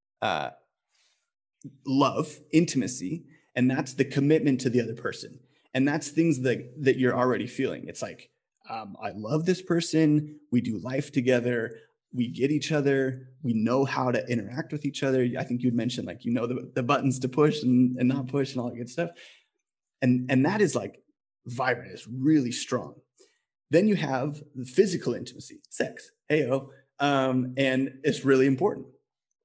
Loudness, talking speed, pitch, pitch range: -27 LUFS, 175 wpm, 135 Hz, 125-150 Hz